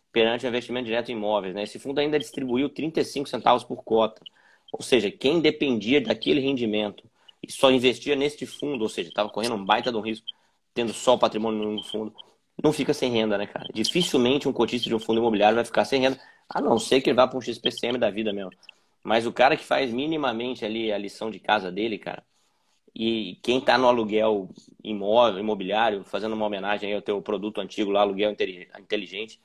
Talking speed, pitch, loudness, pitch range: 205 wpm, 110 Hz, -25 LUFS, 105-125 Hz